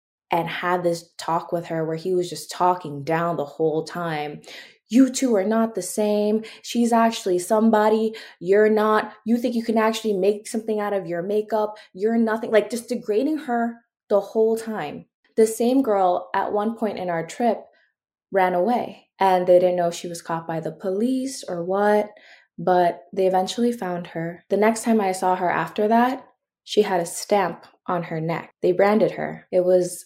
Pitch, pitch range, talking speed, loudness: 200 Hz, 175-220 Hz, 190 wpm, -22 LUFS